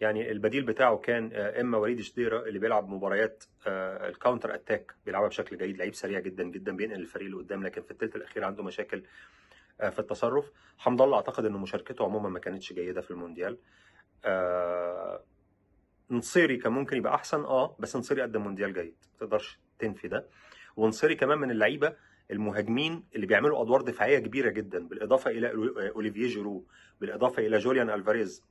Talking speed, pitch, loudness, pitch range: 160 wpm, 110 Hz, -30 LUFS, 100-120 Hz